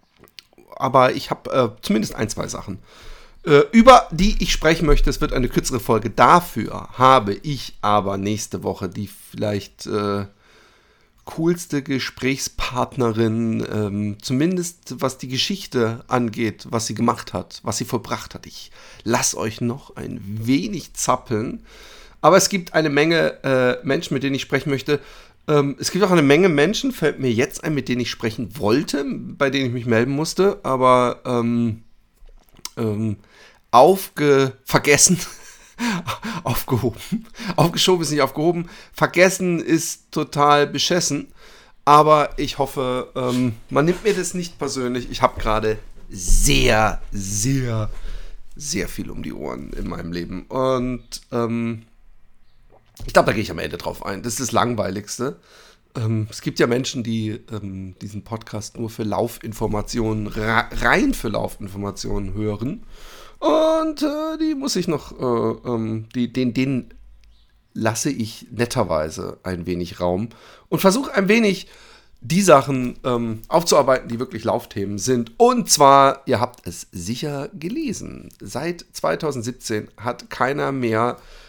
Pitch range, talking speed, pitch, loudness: 110-150 Hz, 145 wpm, 125 Hz, -20 LUFS